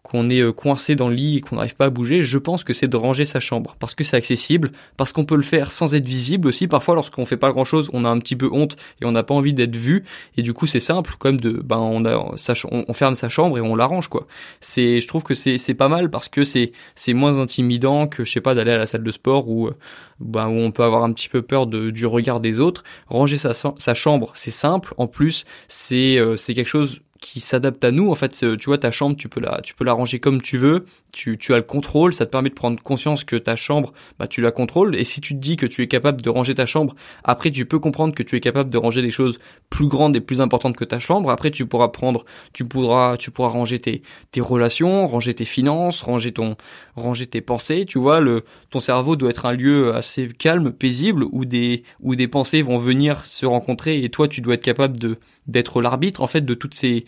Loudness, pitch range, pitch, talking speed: -19 LUFS, 120-145 Hz, 130 Hz, 260 wpm